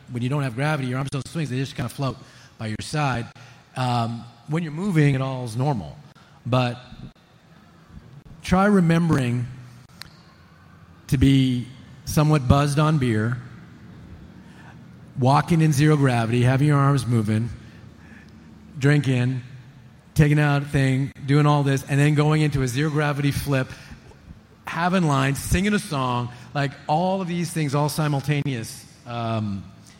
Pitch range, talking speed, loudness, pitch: 120-150 Hz, 140 wpm, -22 LUFS, 135 Hz